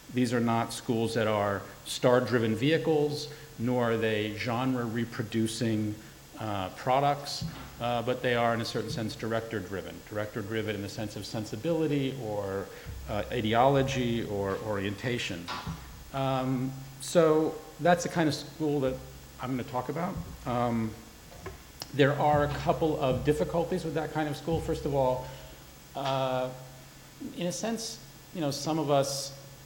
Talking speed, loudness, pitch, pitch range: 145 wpm, -30 LUFS, 130 Hz, 115-150 Hz